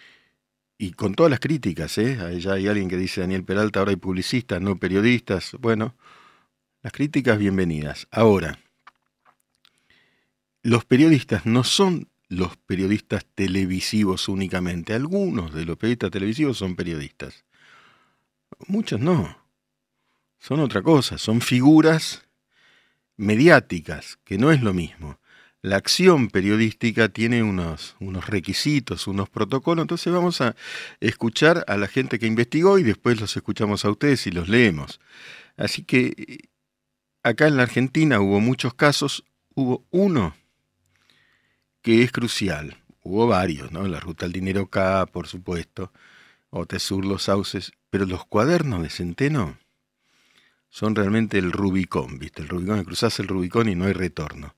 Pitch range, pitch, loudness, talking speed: 95-125 Hz, 105 Hz, -22 LUFS, 140 wpm